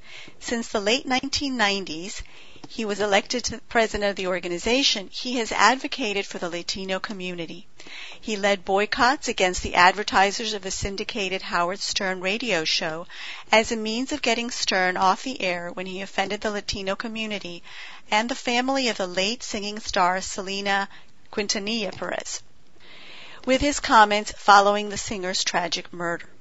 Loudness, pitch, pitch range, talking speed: -23 LUFS, 205 Hz, 185-225 Hz, 150 wpm